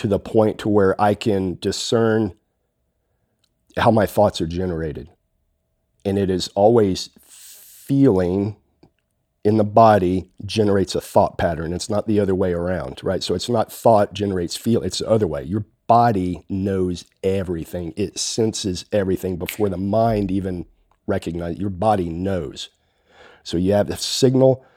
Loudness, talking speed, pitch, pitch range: -20 LUFS, 150 wpm, 100 Hz, 90-105 Hz